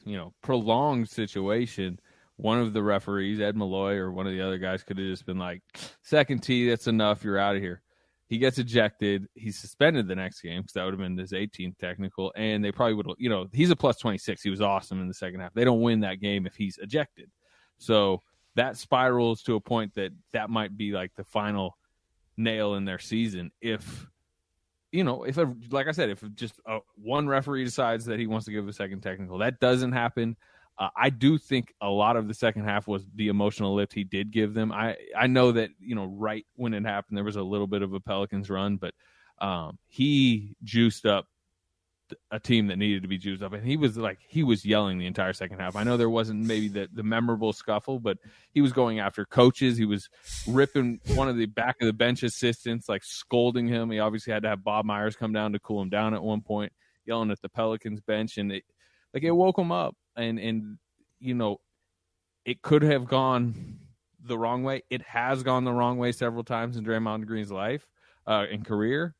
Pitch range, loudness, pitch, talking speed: 100-120 Hz, -28 LUFS, 110 Hz, 220 wpm